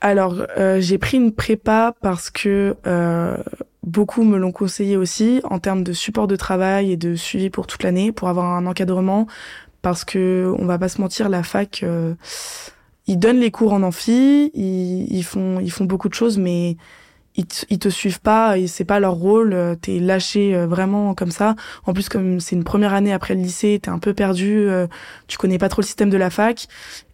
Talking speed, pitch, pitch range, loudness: 215 wpm, 195 Hz, 185-210 Hz, -19 LUFS